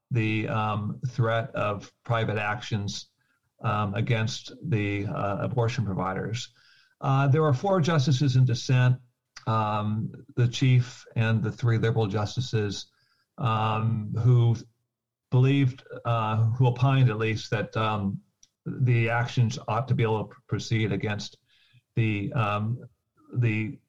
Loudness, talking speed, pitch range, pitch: -26 LUFS, 125 wpm, 110-125 Hz, 115 Hz